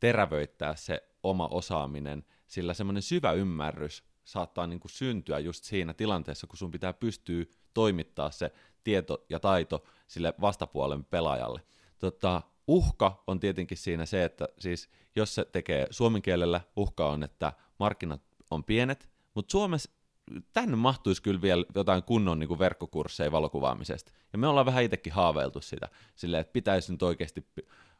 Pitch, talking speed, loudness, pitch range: 90 Hz, 150 wpm, -31 LUFS, 85-100 Hz